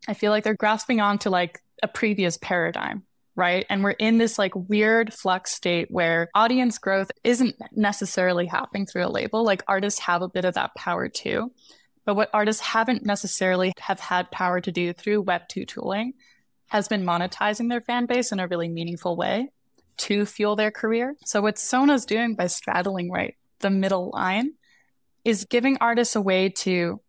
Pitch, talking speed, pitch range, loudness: 205 Hz, 180 wpm, 185-225 Hz, -24 LUFS